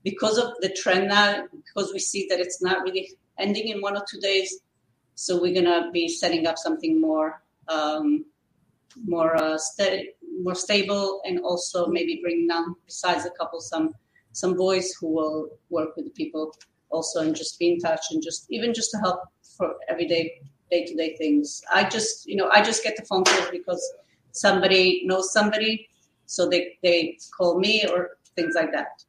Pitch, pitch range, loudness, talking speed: 180 Hz, 165-200 Hz, -24 LUFS, 190 wpm